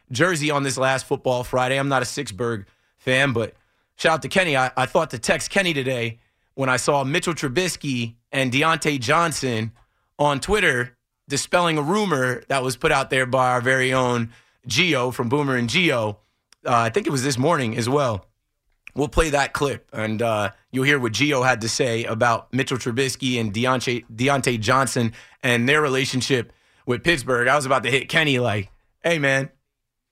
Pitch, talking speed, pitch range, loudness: 130 Hz, 185 wpm, 120-140 Hz, -21 LUFS